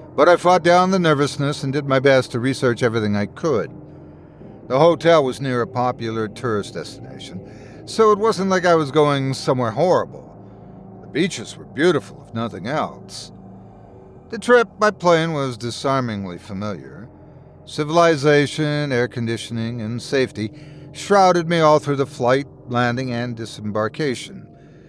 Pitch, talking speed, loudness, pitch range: 135 Hz, 145 wpm, -19 LUFS, 115-155 Hz